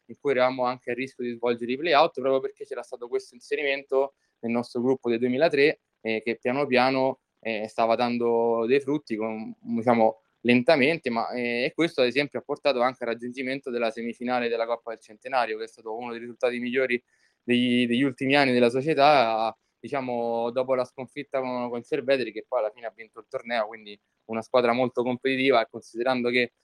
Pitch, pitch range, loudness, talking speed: 125 Hz, 115-135 Hz, -25 LUFS, 195 wpm